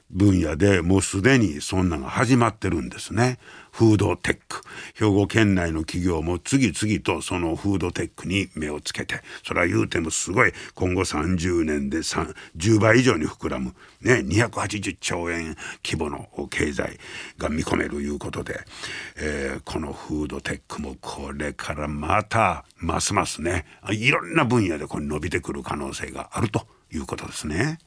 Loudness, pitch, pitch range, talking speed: -24 LUFS, 90 Hz, 75-105 Hz, 310 characters per minute